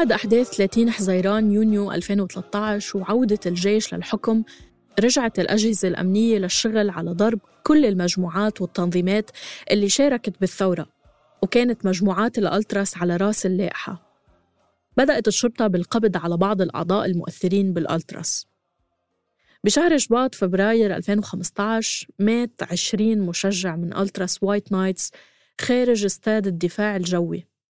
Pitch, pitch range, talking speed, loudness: 200 Hz, 185-220 Hz, 110 wpm, -21 LUFS